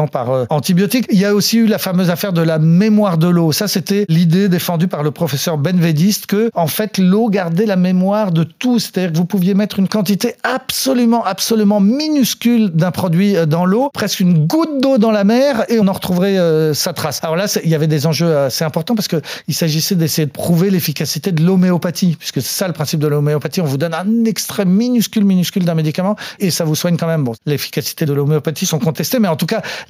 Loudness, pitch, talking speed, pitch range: -15 LUFS, 185 Hz, 220 wpm, 160-210 Hz